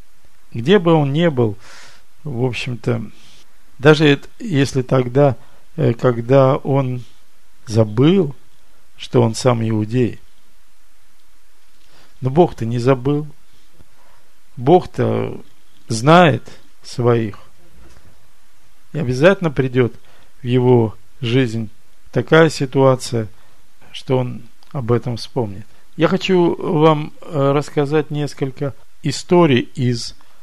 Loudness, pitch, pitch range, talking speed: -17 LUFS, 130 Hz, 115-145 Hz, 85 wpm